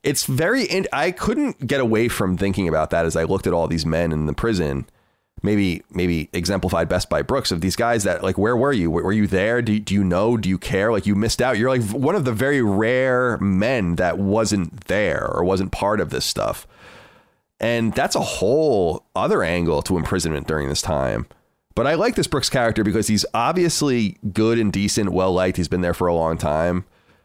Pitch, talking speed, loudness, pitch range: 100 Hz, 215 wpm, -20 LUFS, 90-115 Hz